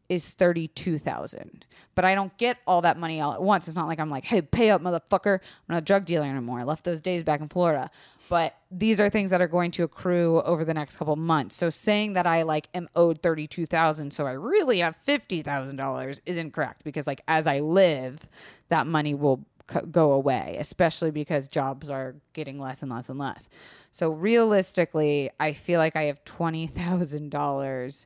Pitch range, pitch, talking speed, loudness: 145-180 Hz, 160 Hz, 200 wpm, -26 LUFS